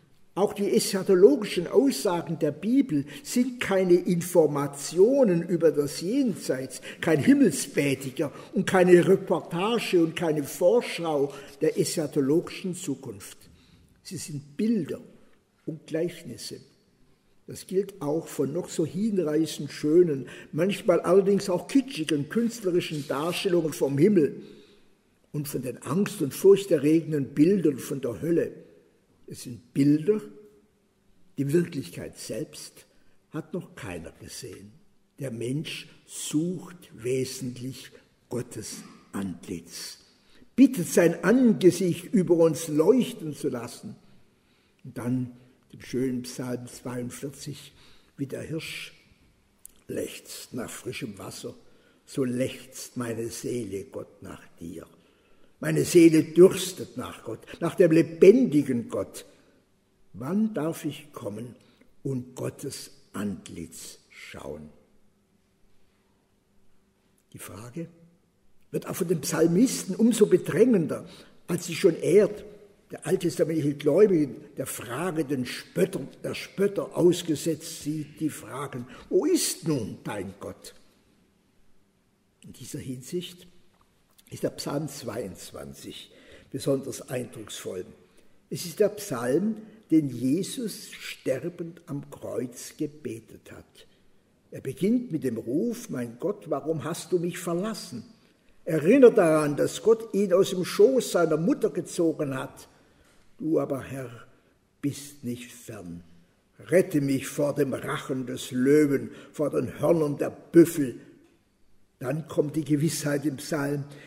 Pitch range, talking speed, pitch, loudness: 135-185 Hz, 110 wpm, 160 Hz, -26 LUFS